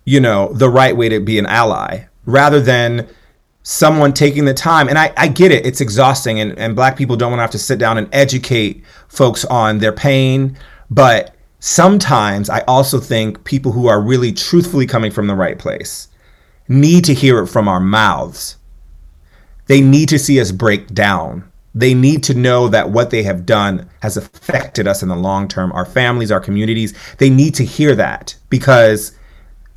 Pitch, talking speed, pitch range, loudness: 120 Hz, 190 wpm, 105-135 Hz, -12 LUFS